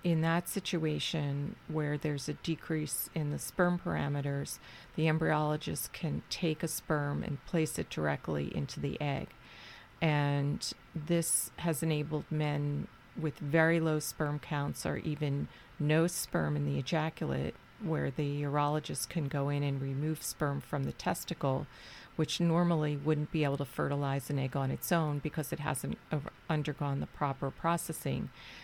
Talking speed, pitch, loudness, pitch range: 150 wpm, 150 Hz, -34 LUFS, 140-160 Hz